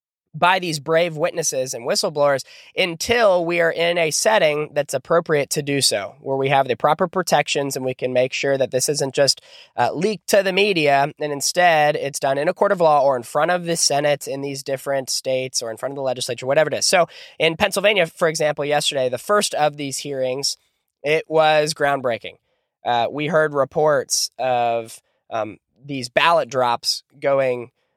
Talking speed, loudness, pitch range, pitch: 190 wpm, -19 LUFS, 135-165 Hz, 145 Hz